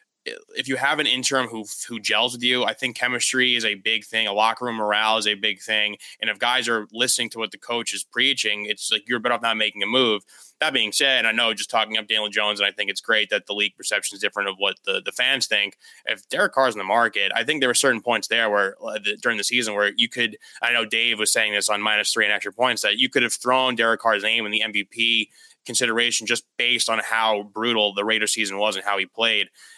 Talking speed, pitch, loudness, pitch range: 265 wpm, 115 Hz, -21 LUFS, 105-120 Hz